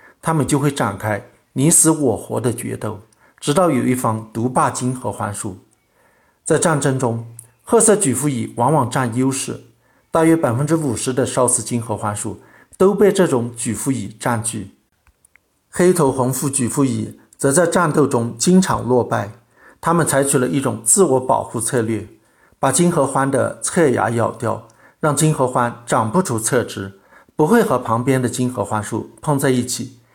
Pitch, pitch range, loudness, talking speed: 125 Hz, 115-145 Hz, -18 LUFS, 245 characters per minute